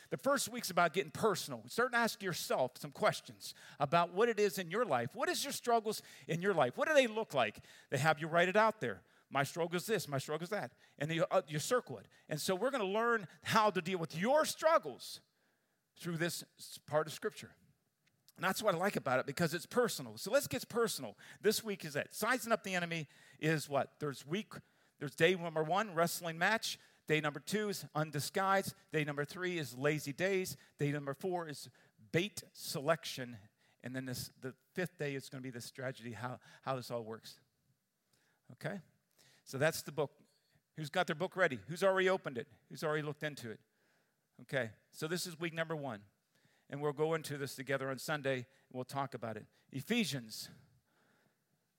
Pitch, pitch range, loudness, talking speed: 160 Hz, 140-195 Hz, -37 LUFS, 205 wpm